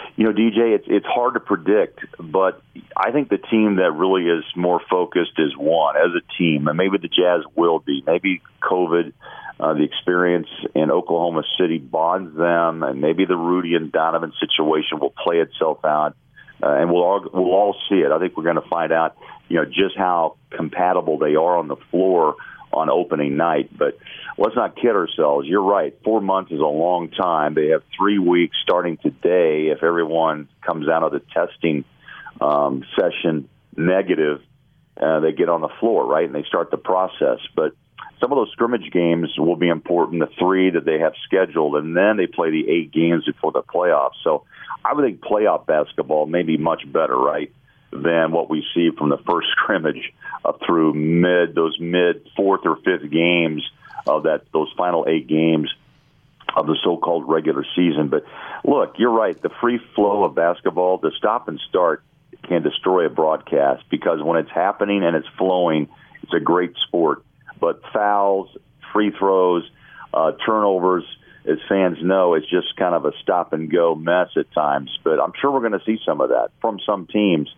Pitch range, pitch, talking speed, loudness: 80-95 Hz, 85 Hz, 190 wpm, -19 LUFS